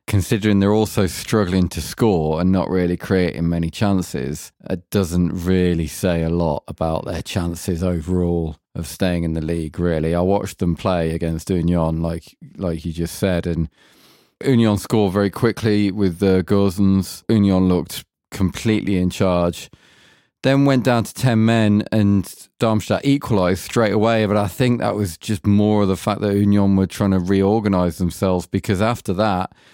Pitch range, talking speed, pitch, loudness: 85-105 Hz, 165 wpm, 95 Hz, -19 LUFS